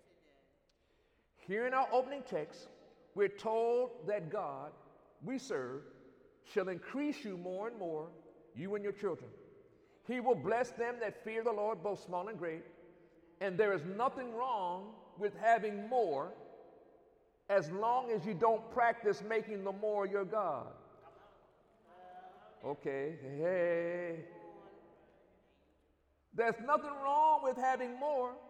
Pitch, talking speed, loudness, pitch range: 215 Hz, 125 wpm, -37 LUFS, 180-245 Hz